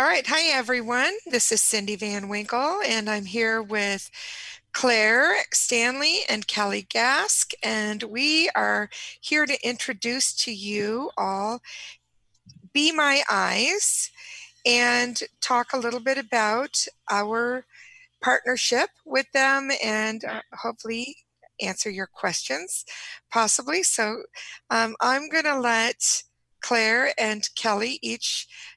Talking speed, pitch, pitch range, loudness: 120 wpm, 245 Hz, 215-275 Hz, -23 LUFS